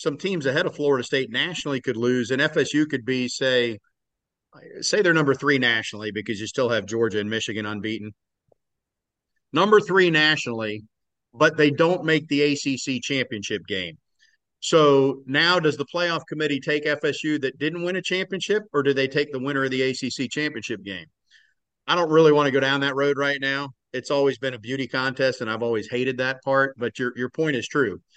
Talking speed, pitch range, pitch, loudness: 195 wpm, 125-150 Hz, 135 Hz, -23 LUFS